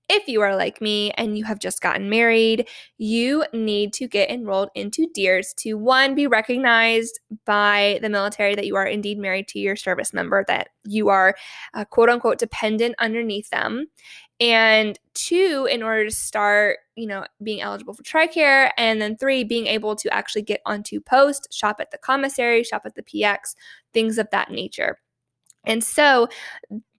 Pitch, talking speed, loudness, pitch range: 220 Hz, 175 wpm, -20 LUFS, 205-245 Hz